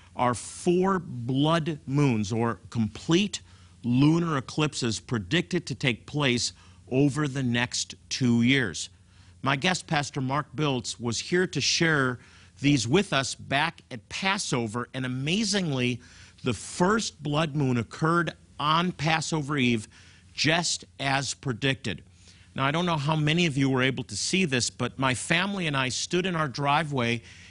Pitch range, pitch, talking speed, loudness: 115-155 Hz, 130 Hz, 145 wpm, -26 LUFS